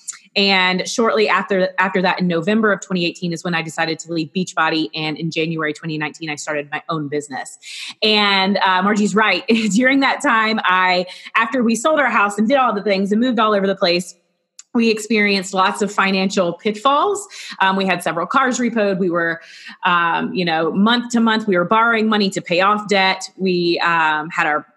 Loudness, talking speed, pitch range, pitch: -17 LUFS, 195 wpm, 170-215 Hz, 190 Hz